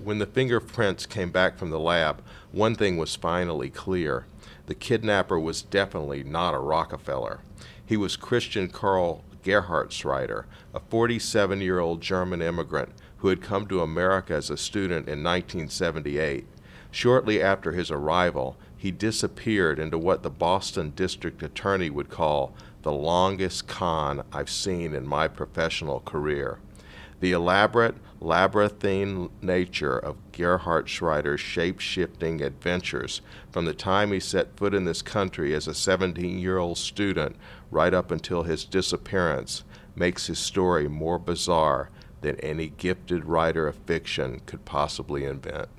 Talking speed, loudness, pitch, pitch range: 140 wpm, -26 LUFS, 90 Hz, 80-100 Hz